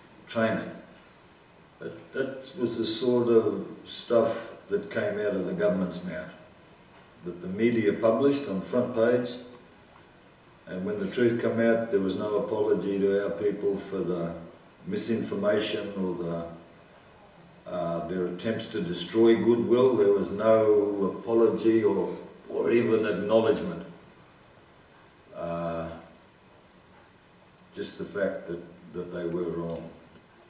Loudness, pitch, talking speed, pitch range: -27 LUFS, 100 Hz, 125 wpm, 85-115 Hz